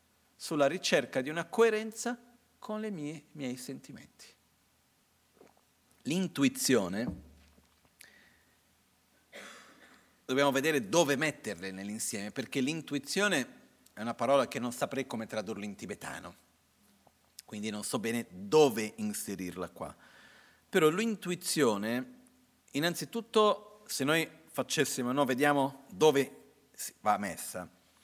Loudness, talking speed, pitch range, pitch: -32 LUFS, 100 wpm, 110-180 Hz, 140 Hz